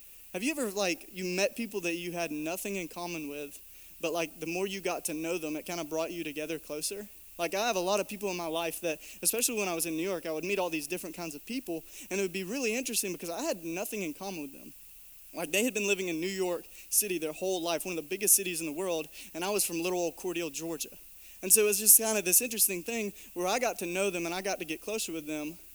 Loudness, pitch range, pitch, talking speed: -30 LUFS, 165-200 Hz, 180 Hz, 285 wpm